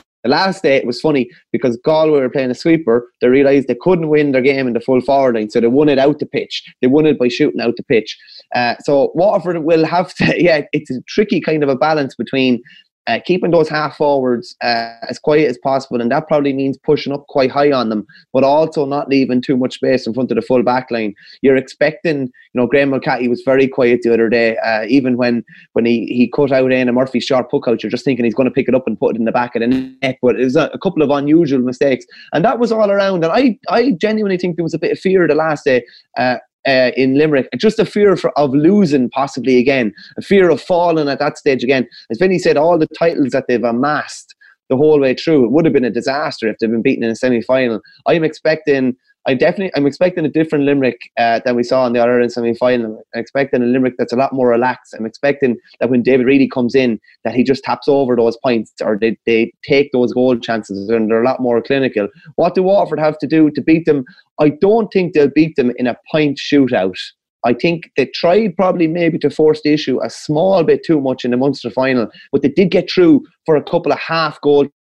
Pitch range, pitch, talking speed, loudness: 125-155 Hz, 135 Hz, 245 wpm, -15 LUFS